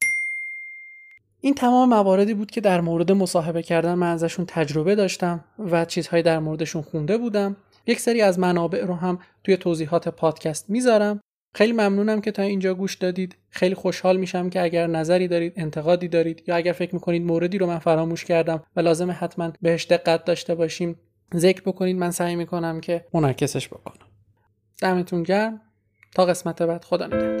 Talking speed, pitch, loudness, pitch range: 165 wpm, 175 Hz, -22 LUFS, 165-190 Hz